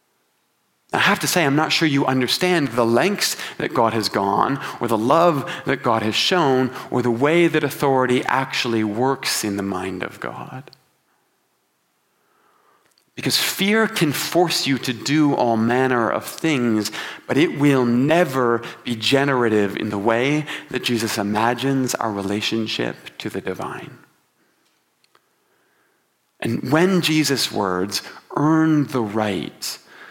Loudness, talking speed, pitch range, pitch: -20 LUFS, 140 wpm, 115-155 Hz, 130 Hz